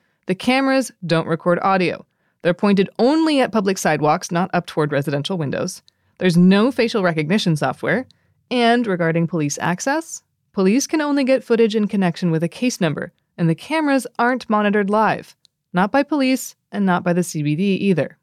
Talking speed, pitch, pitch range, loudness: 170 wpm, 190 Hz, 170-235 Hz, -19 LUFS